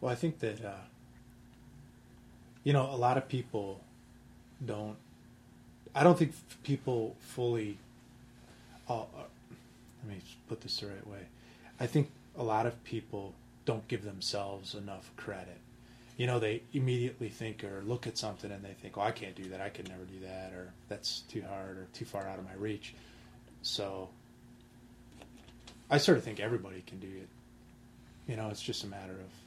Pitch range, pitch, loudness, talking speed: 100-120 Hz, 110 Hz, -36 LUFS, 175 wpm